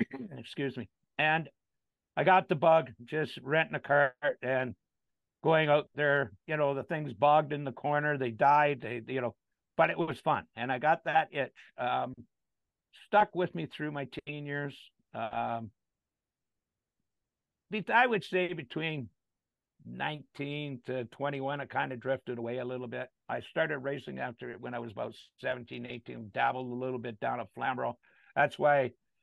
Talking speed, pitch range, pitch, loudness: 170 wpm, 125-155 Hz, 140 Hz, -32 LUFS